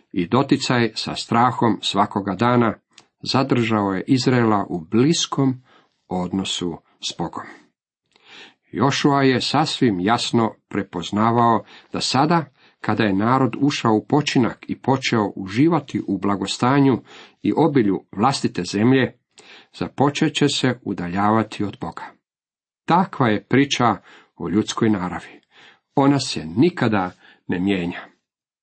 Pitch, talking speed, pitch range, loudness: 115 Hz, 110 wpm, 100-135 Hz, -20 LUFS